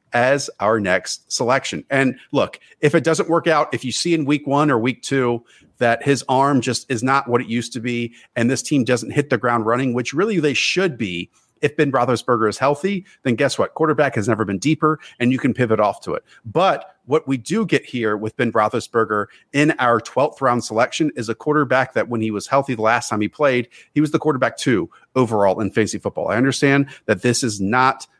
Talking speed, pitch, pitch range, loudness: 225 wpm, 125 Hz, 115-145 Hz, -19 LUFS